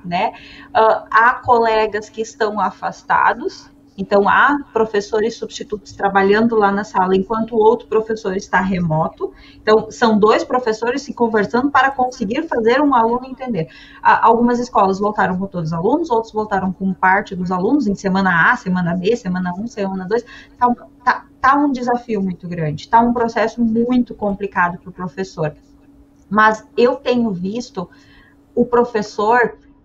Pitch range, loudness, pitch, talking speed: 195-240 Hz, -17 LUFS, 220 Hz, 155 wpm